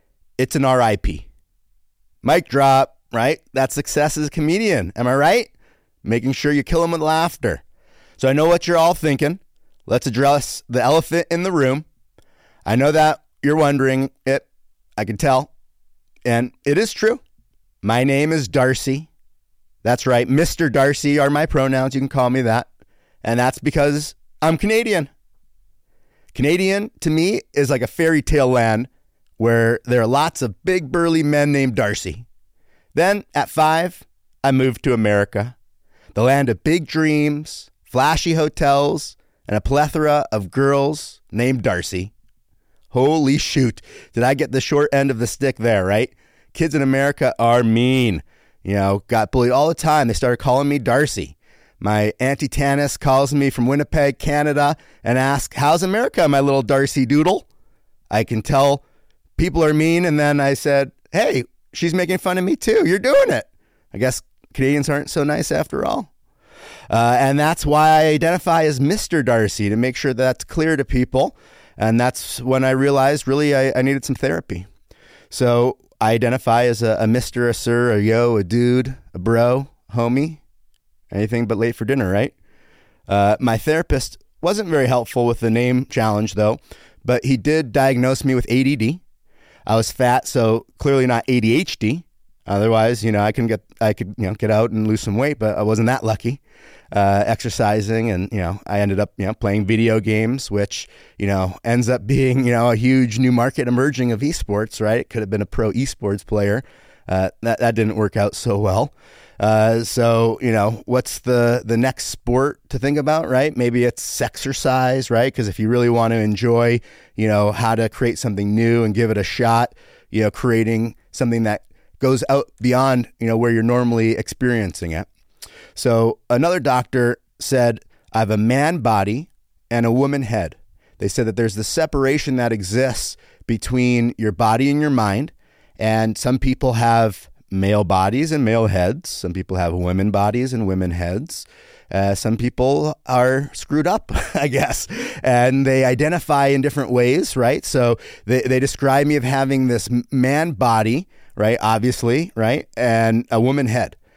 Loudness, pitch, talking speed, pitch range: -18 LUFS, 125 Hz, 175 wpm, 110-140 Hz